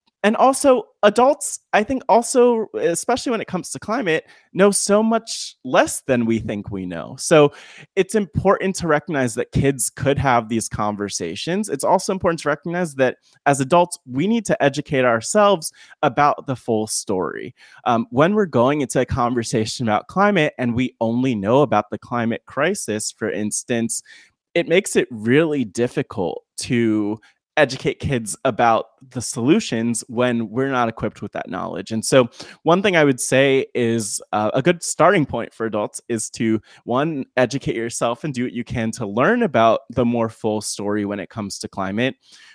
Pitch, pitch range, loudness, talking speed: 130 Hz, 115-170 Hz, -20 LUFS, 175 wpm